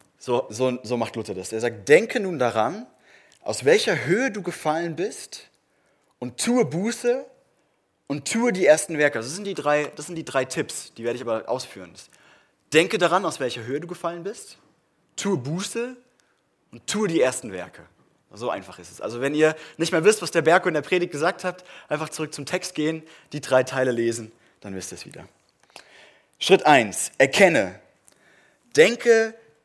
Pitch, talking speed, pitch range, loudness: 160 Hz, 185 wpm, 130-190 Hz, -23 LUFS